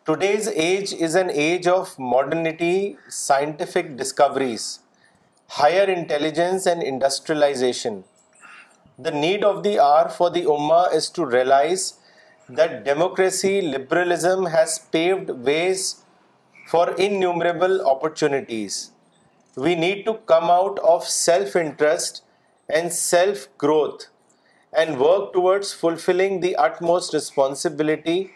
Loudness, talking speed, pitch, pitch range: -21 LUFS, 110 wpm, 175 Hz, 155-190 Hz